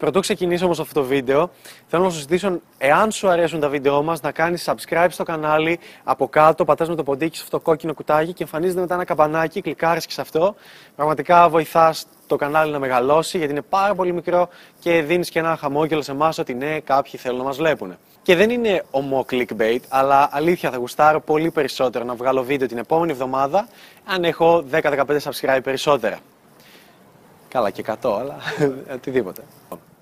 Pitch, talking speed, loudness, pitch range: 155 Hz, 185 wpm, -20 LUFS, 140-170 Hz